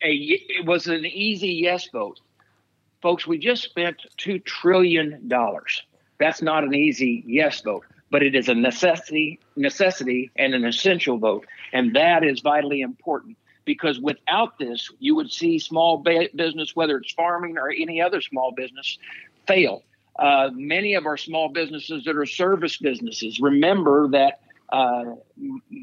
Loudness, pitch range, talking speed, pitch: -22 LUFS, 140-185 Hz, 155 wpm, 160 Hz